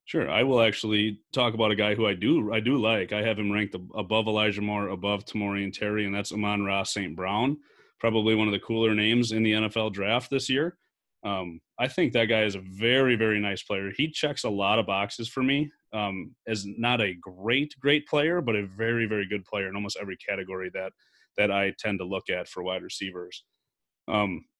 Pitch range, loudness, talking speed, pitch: 100-115 Hz, -27 LUFS, 220 wpm, 105 Hz